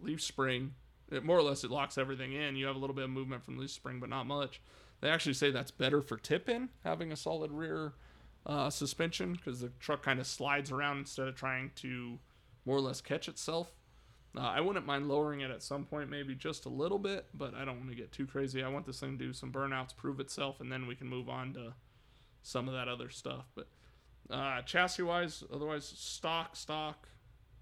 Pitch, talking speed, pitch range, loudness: 135 Hz, 225 wpm, 130-150 Hz, -37 LUFS